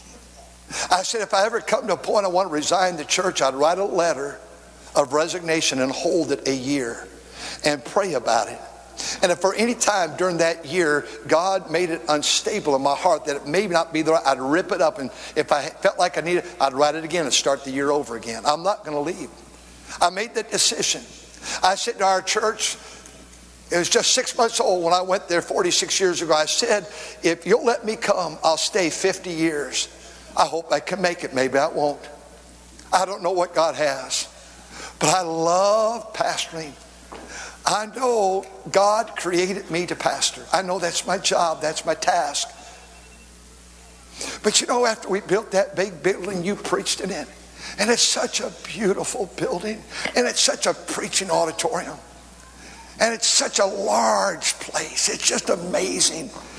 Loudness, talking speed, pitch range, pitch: -21 LUFS, 190 wpm, 150-195 Hz, 175 Hz